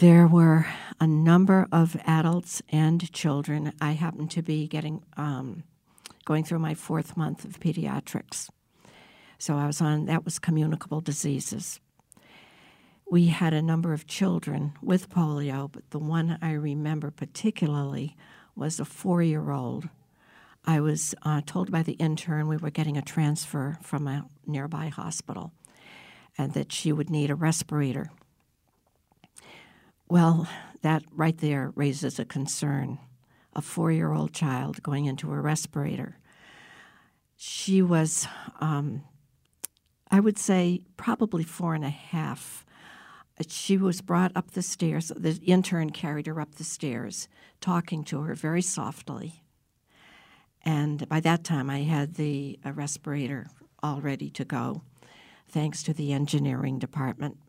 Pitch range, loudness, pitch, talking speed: 145-165 Hz, -27 LUFS, 155 Hz, 140 wpm